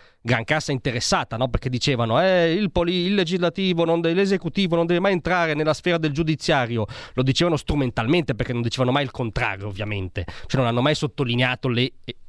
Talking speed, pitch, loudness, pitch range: 185 wpm, 140 Hz, -22 LUFS, 125-170 Hz